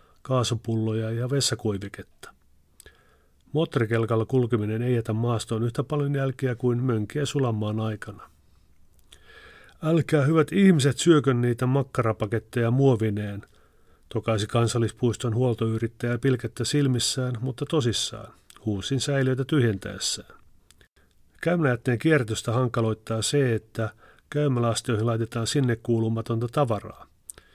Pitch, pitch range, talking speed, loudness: 120 Hz, 110-135 Hz, 90 wpm, -25 LUFS